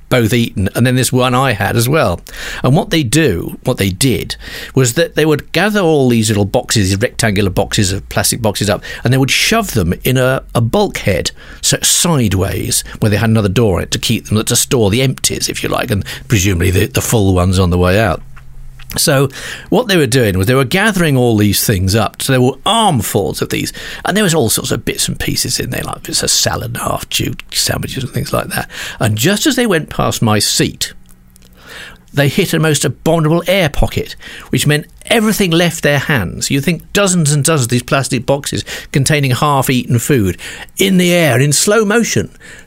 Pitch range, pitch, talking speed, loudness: 110-155 Hz, 130 Hz, 210 wpm, -13 LUFS